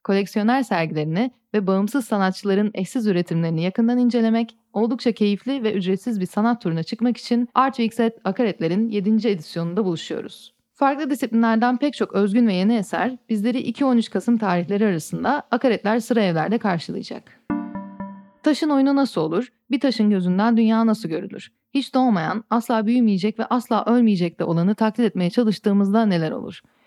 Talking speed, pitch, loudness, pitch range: 145 wpm, 220 Hz, -21 LUFS, 195-240 Hz